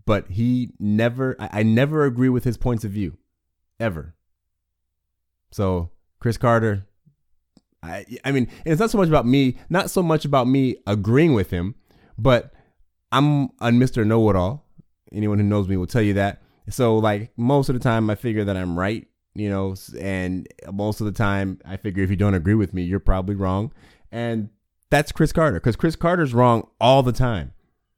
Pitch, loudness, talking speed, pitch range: 110 Hz, -21 LUFS, 185 wpm, 95-125 Hz